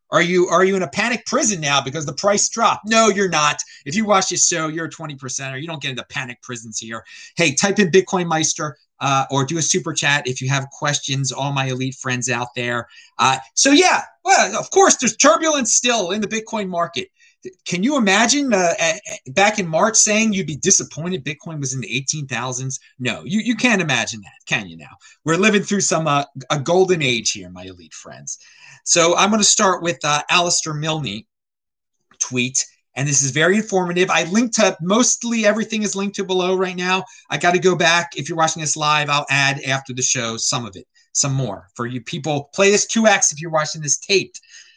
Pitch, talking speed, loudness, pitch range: 165 Hz, 215 wpm, -18 LUFS, 135-200 Hz